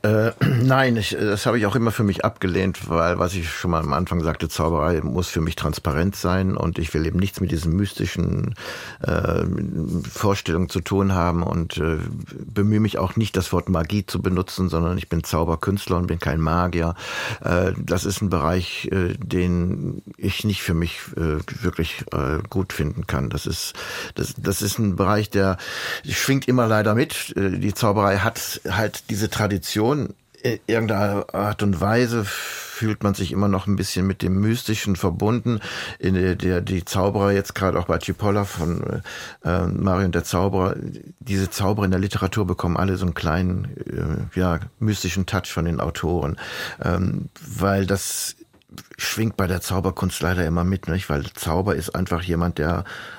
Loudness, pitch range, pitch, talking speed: -23 LUFS, 85-100 Hz, 95 Hz, 180 wpm